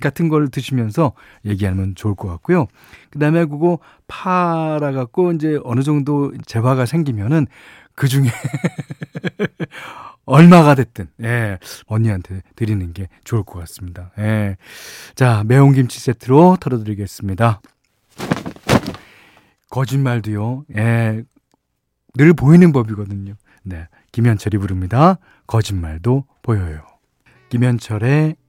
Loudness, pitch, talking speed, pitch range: -16 LUFS, 125 Hz, 245 characters per minute, 105-150 Hz